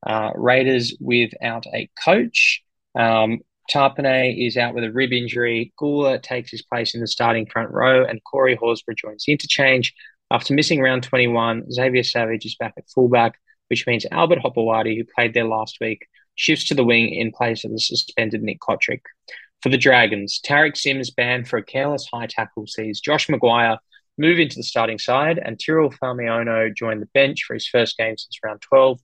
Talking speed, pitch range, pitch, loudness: 185 wpm, 115-130 Hz, 120 Hz, -19 LUFS